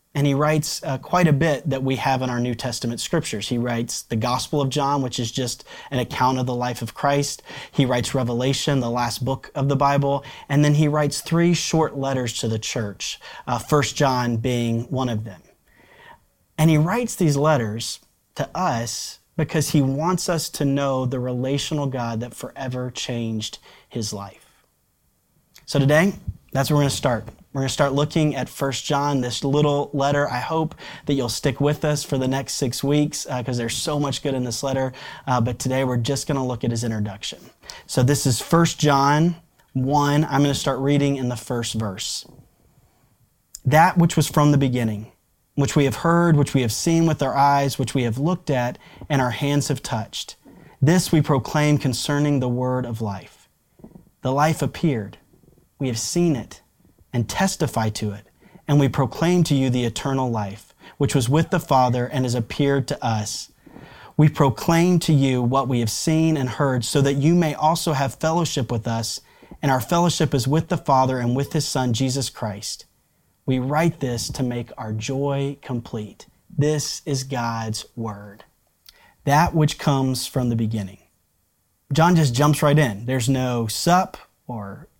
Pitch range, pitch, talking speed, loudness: 120-150 Hz, 135 Hz, 190 wpm, -22 LUFS